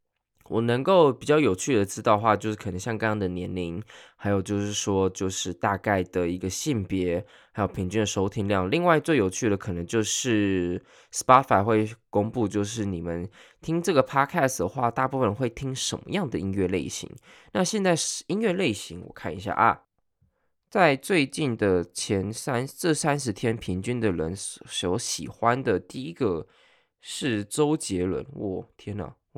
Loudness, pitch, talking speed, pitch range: -26 LUFS, 105 Hz, 270 characters per minute, 95-130 Hz